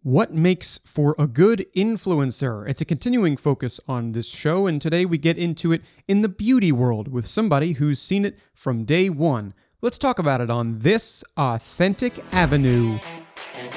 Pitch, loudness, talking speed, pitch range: 160 Hz, -21 LUFS, 170 wpm, 130-185 Hz